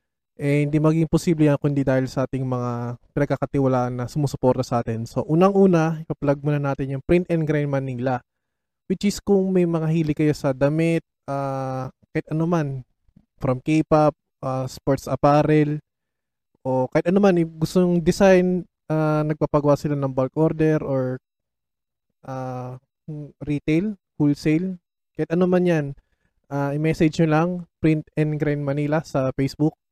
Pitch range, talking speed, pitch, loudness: 135-160 Hz, 145 wpm, 150 Hz, -22 LUFS